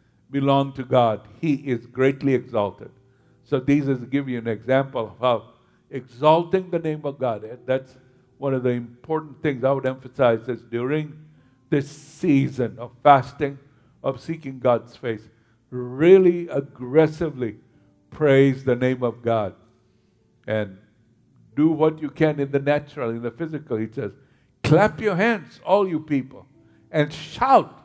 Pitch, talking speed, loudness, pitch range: 130 Hz, 145 wpm, -22 LUFS, 120-150 Hz